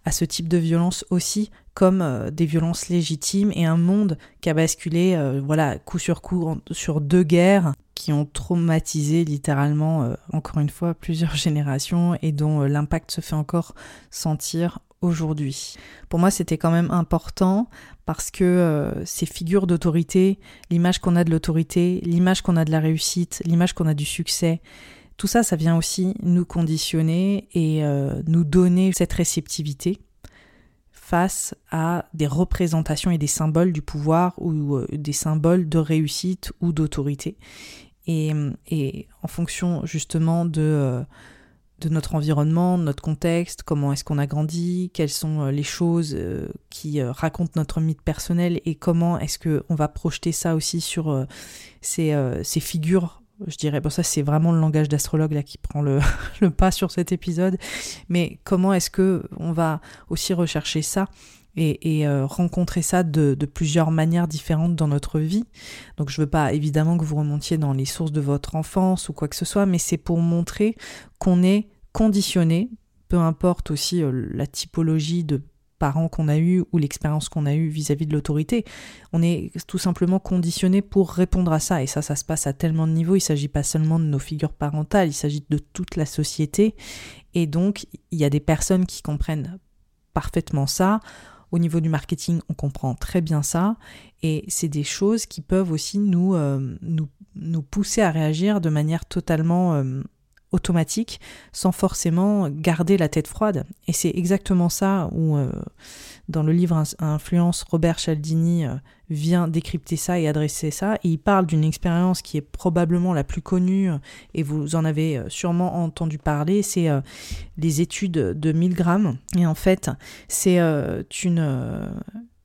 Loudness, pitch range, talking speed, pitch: -22 LUFS, 150-180 Hz, 175 wpm, 165 Hz